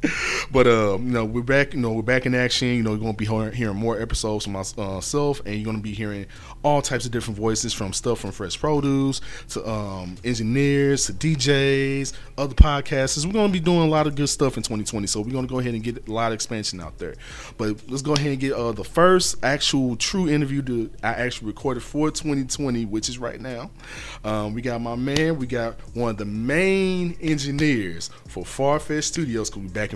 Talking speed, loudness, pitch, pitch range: 220 wpm, -23 LUFS, 125 Hz, 110-140 Hz